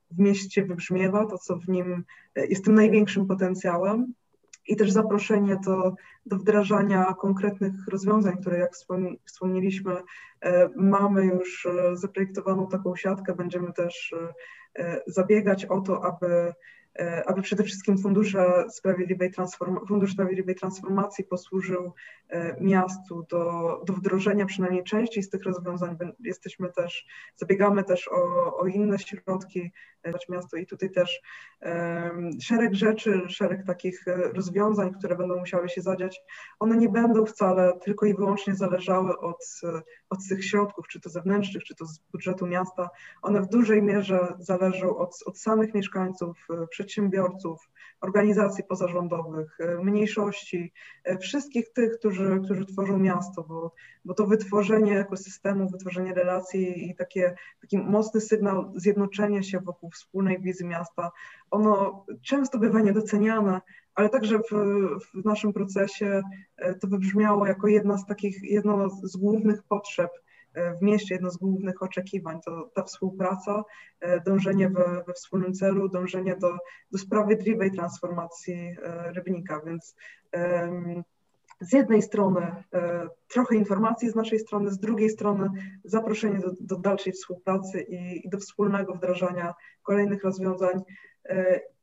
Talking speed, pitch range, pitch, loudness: 130 wpm, 180-205 Hz, 190 Hz, -26 LUFS